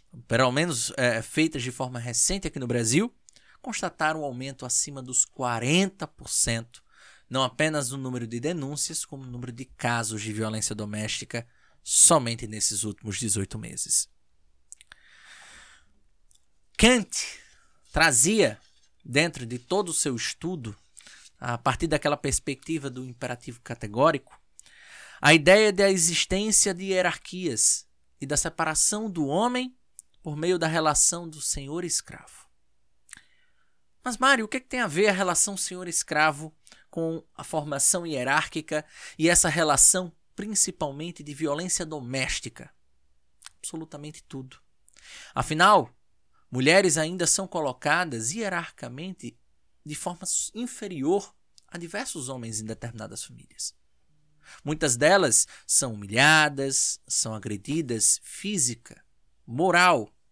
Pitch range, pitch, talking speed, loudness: 120-175 Hz, 150 Hz, 115 wpm, -24 LUFS